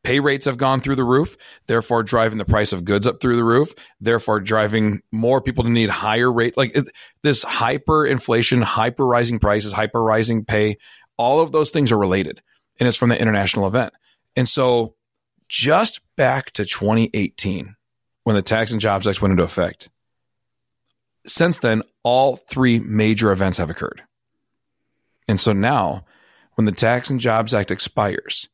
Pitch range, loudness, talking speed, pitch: 105-125 Hz, -19 LUFS, 170 wpm, 115 Hz